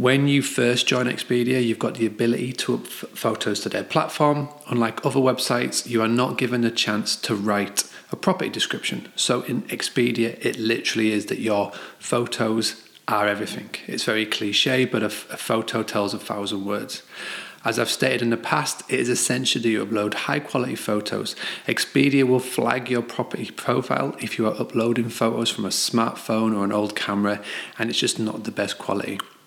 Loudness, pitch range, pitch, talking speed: -23 LUFS, 110-125 Hz, 115 Hz, 185 wpm